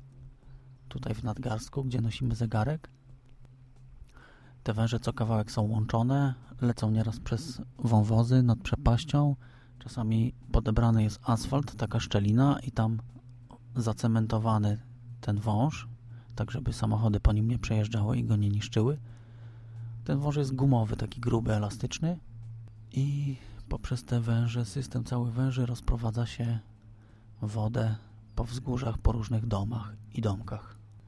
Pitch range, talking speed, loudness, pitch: 110-125 Hz, 125 wpm, -30 LUFS, 115 Hz